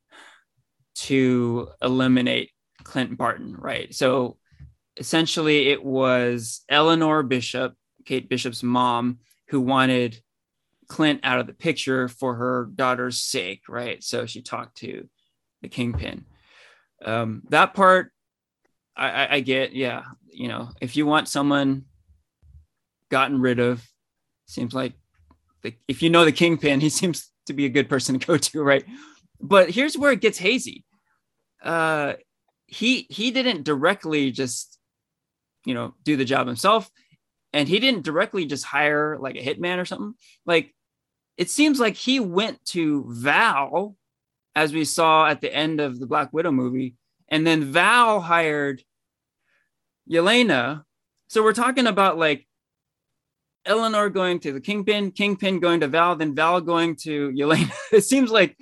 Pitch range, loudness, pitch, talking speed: 130-175 Hz, -21 LUFS, 150 Hz, 145 wpm